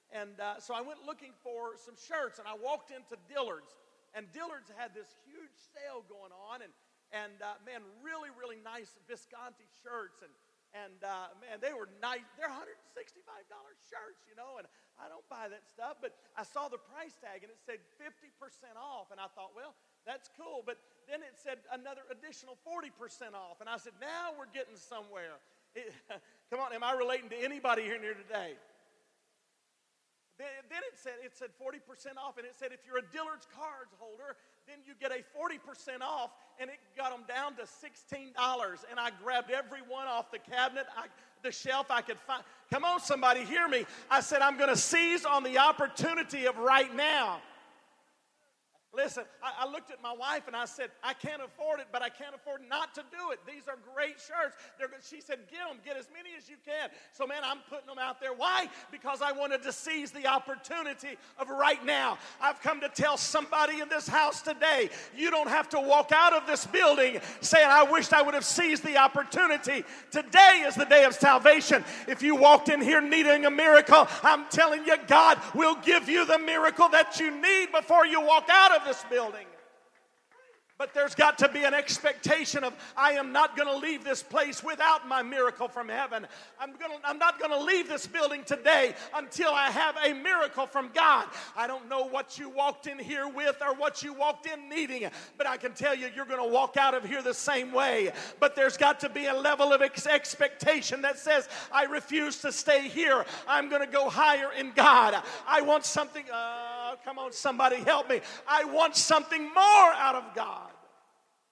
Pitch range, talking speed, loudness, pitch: 255-305 Hz, 205 wpm, -26 LUFS, 280 Hz